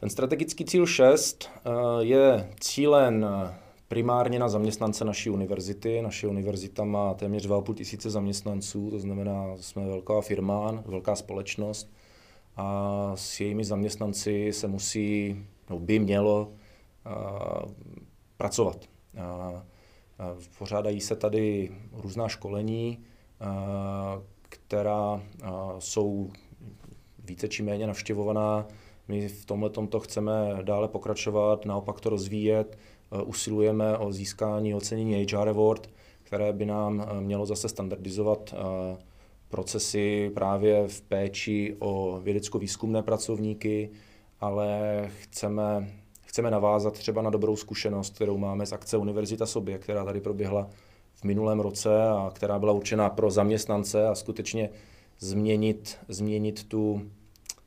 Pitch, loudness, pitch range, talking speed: 105 Hz, -29 LUFS, 100-110 Hz, 110 wpm